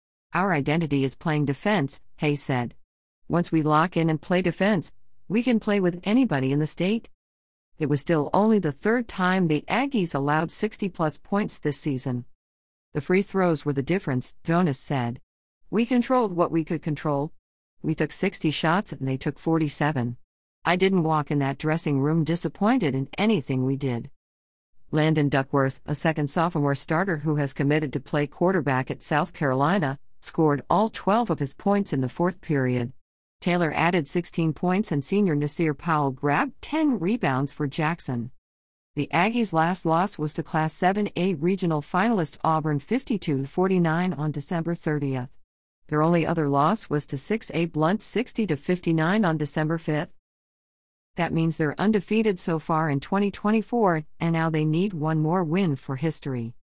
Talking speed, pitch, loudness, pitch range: 160 wpm, 155 Hz, -25 LUFS, 140-180 Hz